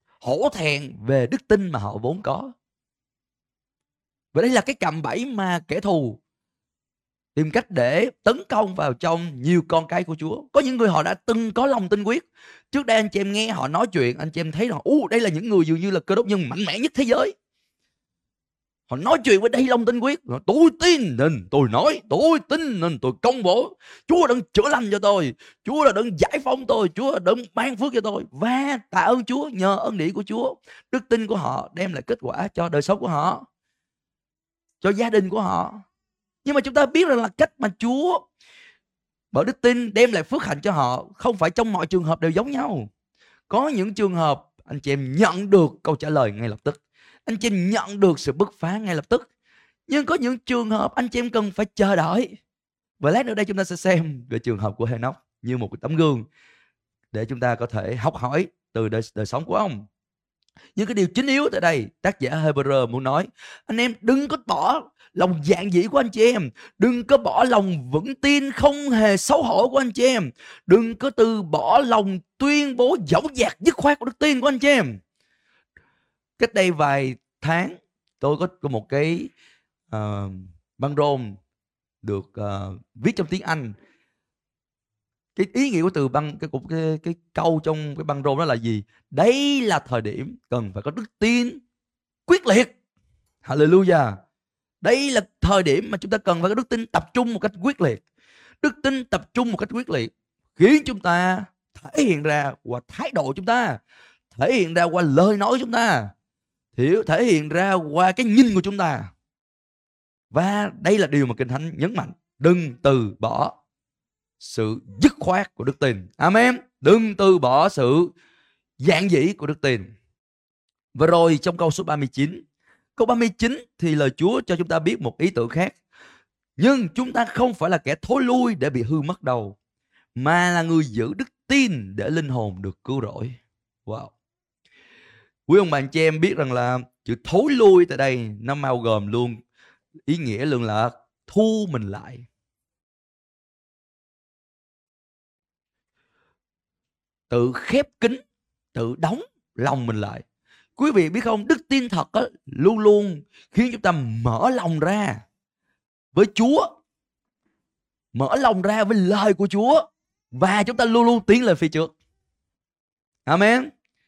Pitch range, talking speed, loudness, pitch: 140-235 Hz, 195 wpm, -21 LUFS, 185 Hz